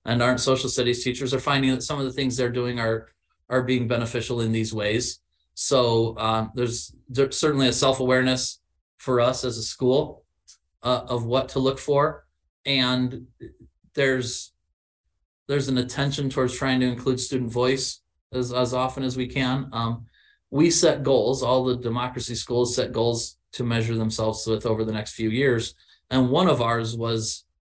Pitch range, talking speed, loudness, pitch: 115-130 Hz, 175 wpm, -24 LUFS, 125 Hz